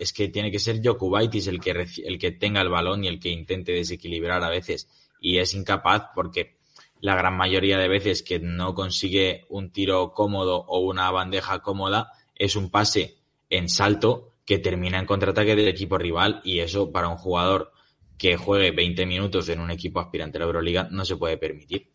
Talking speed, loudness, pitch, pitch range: 195 wpm, -24 LUFS, 95 Hz, 90-100 Hz